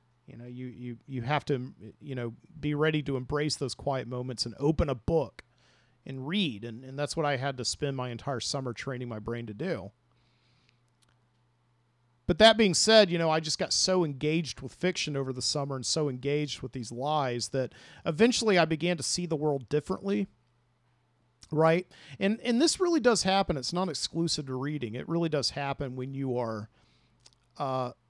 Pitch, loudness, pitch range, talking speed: 135 Hz, -29 LUFS, 125-160 Hz, 190 wpm